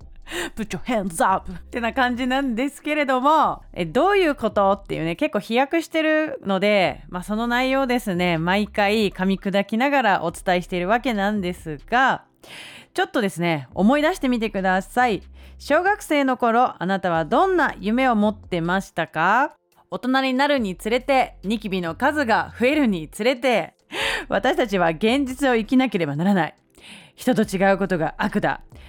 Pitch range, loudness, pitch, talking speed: 185-260 Hz, -21 LUFS, 220 Hz, 335 characters per minute